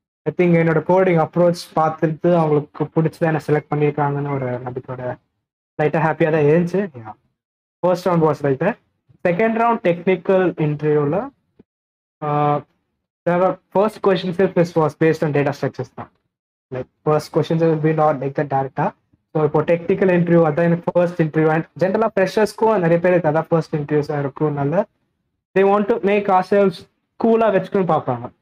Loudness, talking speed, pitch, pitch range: -18 LUFS, 115 wpm, 165 Hz, 150-185 Hz